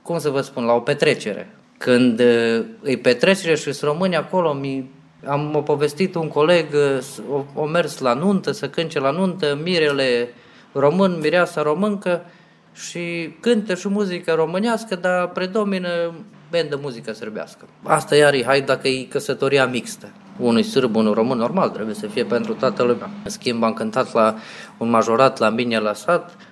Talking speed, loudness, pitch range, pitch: 165 wpm, -20 LUFS, 125-175 Hz, 145 Hz